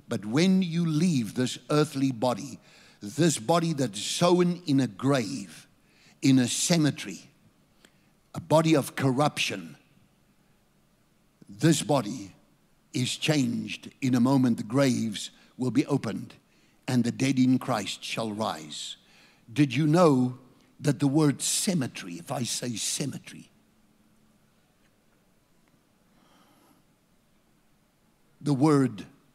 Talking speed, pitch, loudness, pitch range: 110 wpm, 135 Hz, -26 LUFS, 125-155 Hz